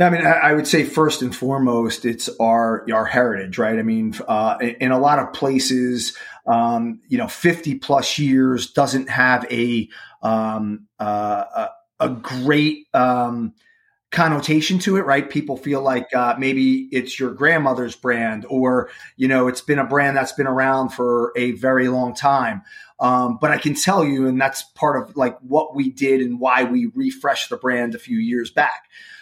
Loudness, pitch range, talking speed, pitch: -19 LUFS, 125-150 Hz, 180 wpm, 130 Hz